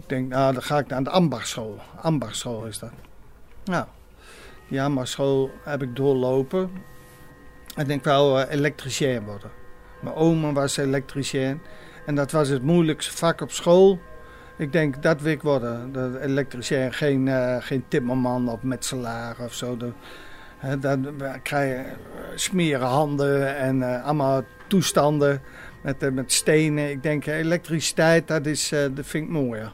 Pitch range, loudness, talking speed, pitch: 130-150 Hz, -23 LUFS, 155 wpm, 140 Hz